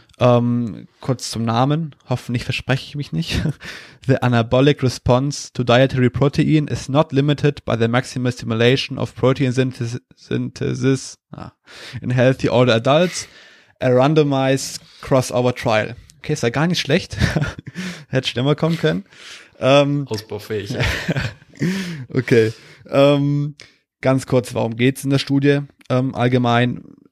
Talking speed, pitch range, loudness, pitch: 125 wpm, 120-145 Hz, -19 LUFS, 130 Hz